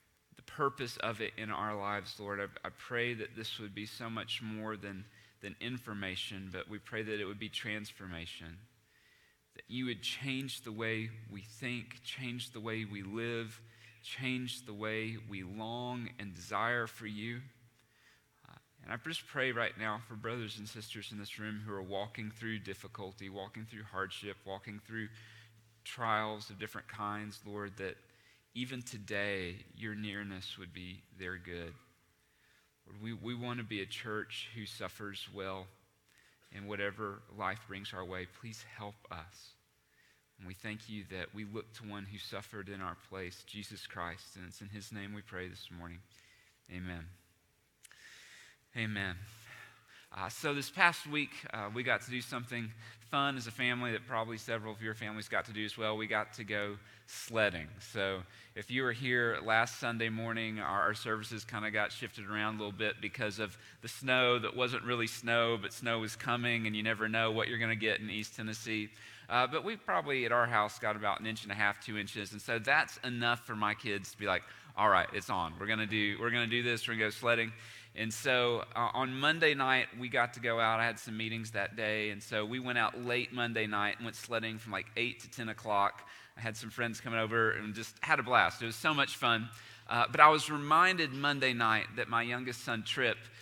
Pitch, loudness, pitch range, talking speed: 110 Hz, -35 LUFS, 105-120 Hz, 200 wpm